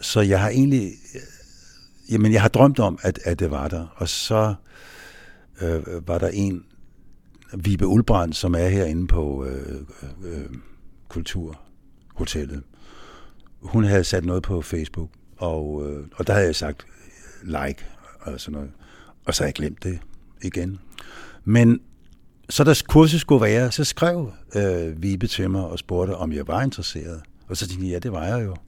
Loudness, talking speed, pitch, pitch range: -22 LUFS, 165 wpm, 90 Hz, 80-105 Hz